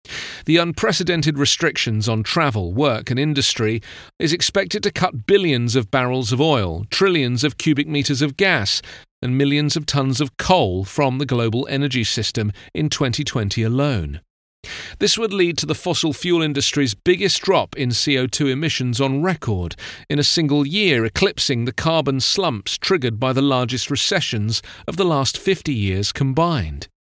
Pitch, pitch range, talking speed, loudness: 140 Hz, 120-160 Hz, 155 wpm, -19 LUFS